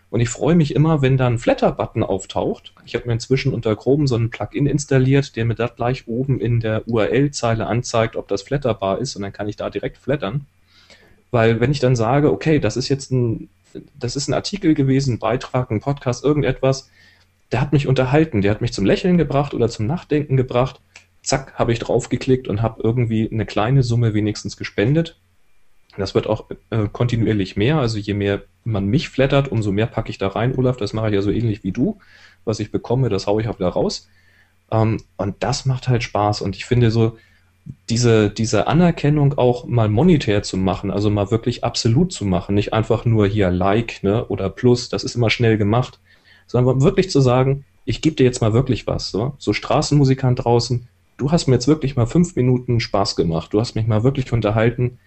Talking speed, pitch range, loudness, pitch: 205 wpm, 105-130 Hz, -19 LUFS, 115 Hz